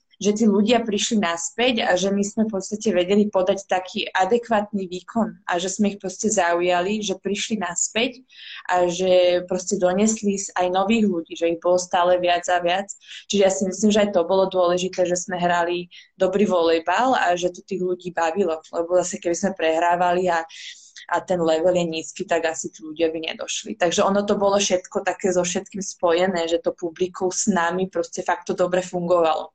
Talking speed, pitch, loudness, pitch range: 195 wpm, 185 Hz, -21 LUFS, 175-200 Hz